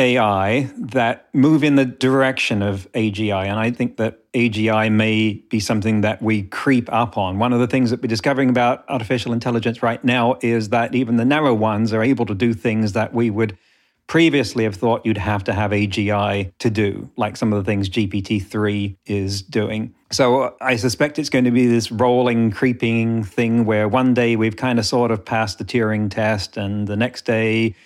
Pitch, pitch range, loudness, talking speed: 115 Hz, 110-125 Hz, -19 LUFS, 200 wpm